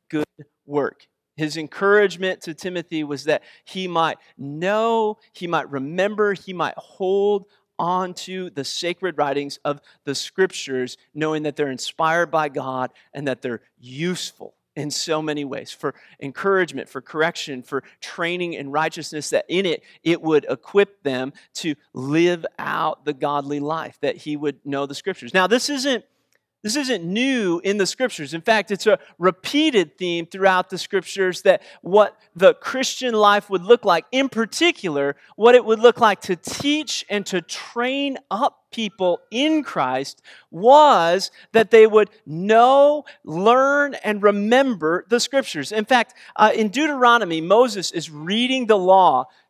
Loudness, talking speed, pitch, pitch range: -20 LUFS, 155 wpm, 185 Hz, 150-220 Hz